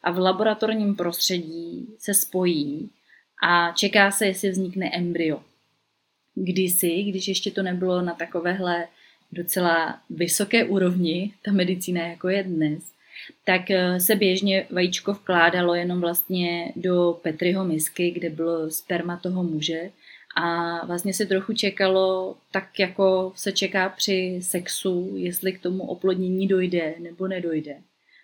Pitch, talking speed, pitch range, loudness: 185 Hz, 125 wpm, 175-195 Hz, -23 LUFS